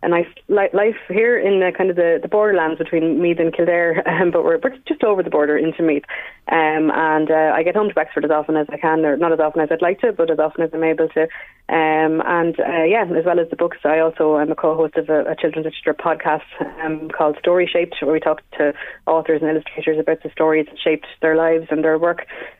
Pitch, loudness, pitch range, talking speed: 160 Hz, -18 LUFS, 155-170 Hz, 245 wpm